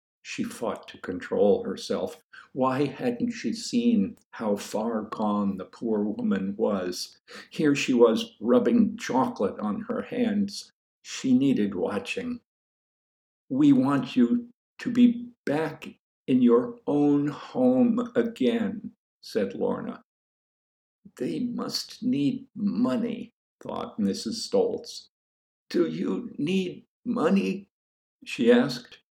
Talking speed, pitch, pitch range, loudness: 110 wpm, 240 Hz, 220-250 Hz, -26 LUFS